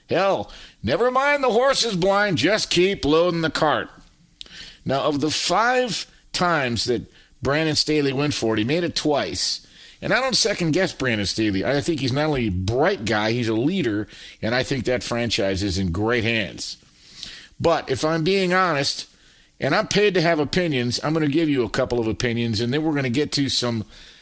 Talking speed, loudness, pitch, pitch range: 205 wpm, -21 LUFS, 140 Hz, 115-170 Hz